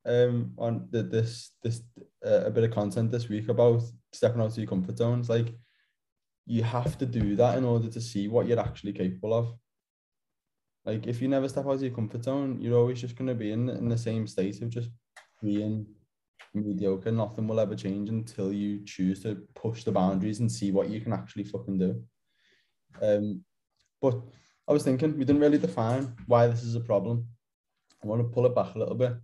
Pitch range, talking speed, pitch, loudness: 105-120 Hz, 205 wpm, 115 Hz, -29 LUFS